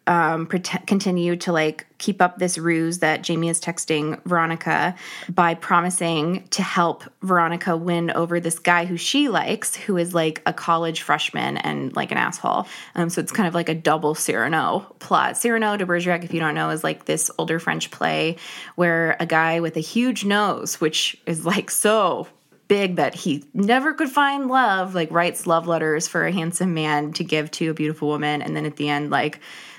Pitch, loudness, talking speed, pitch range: 170 Hz, -21 LUFS, 195 wpm, 160-185 Hz